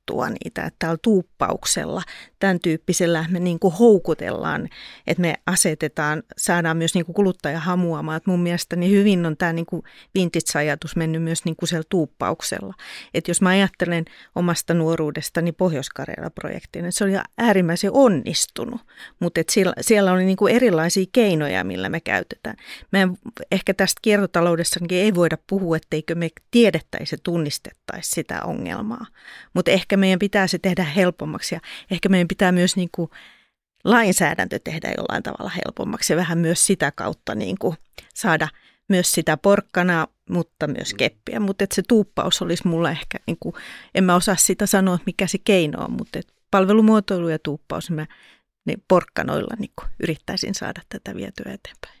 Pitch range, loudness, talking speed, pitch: 165-195 Hz, -21 LUFS, 150 wpm, 180 Hz